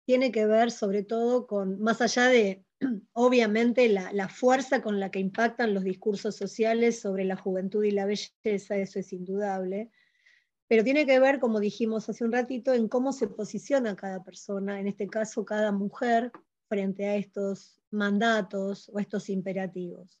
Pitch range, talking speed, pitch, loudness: 195-235 Hz, 165 wpm, 210 Hz, -27 LUFS